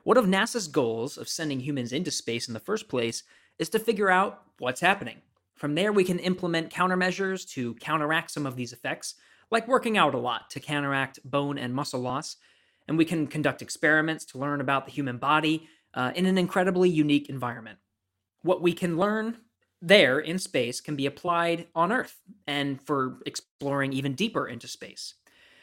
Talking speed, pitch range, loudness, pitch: 185 wpm, 135-185 Hz, -27 LUFS, 155 Hz